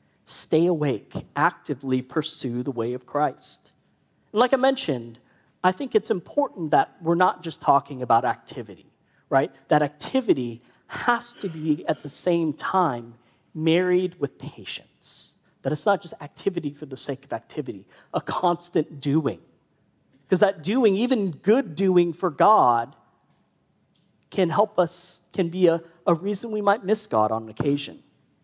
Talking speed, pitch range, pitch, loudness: 150 wpm, 140-195 Hz, 170 Hz, -24 LUFS